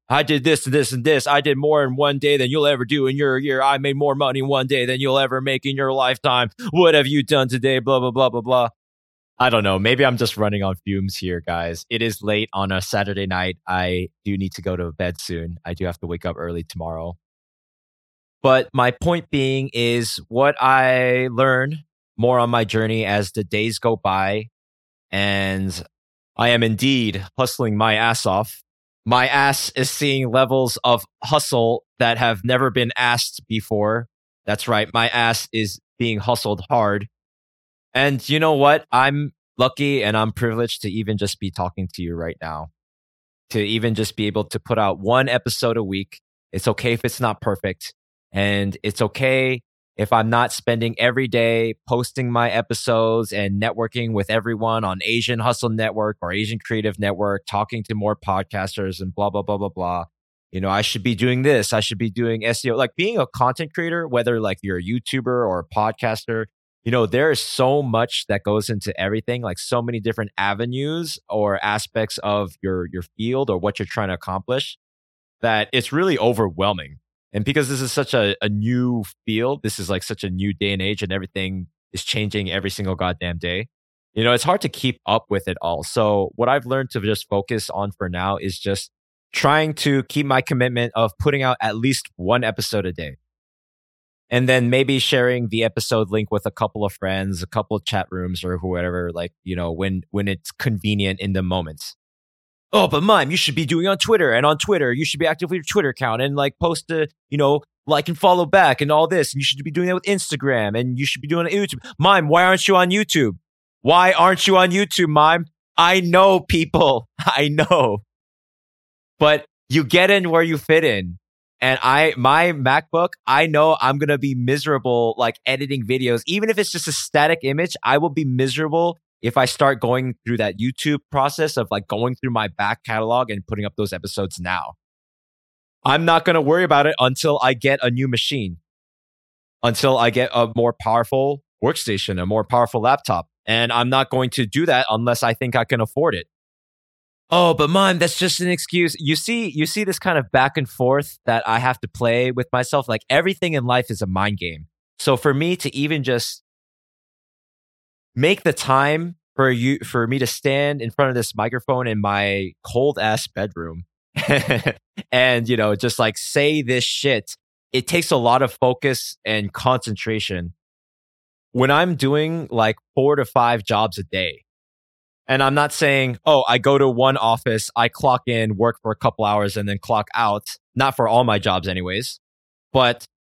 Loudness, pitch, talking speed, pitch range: -19 LUFS, 120 Hz, 200 wpm, 100-135 Hz